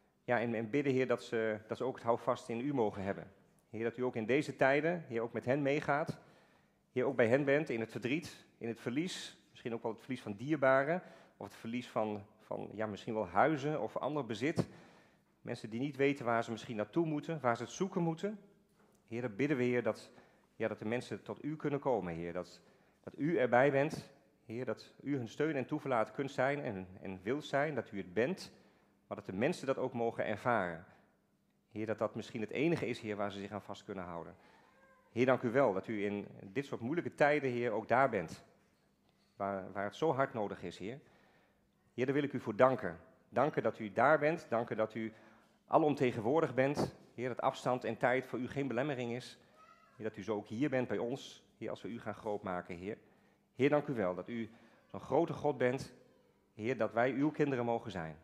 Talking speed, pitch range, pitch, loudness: 225 wpm, 110-140 Hz, 120 Hz, -36 LUFS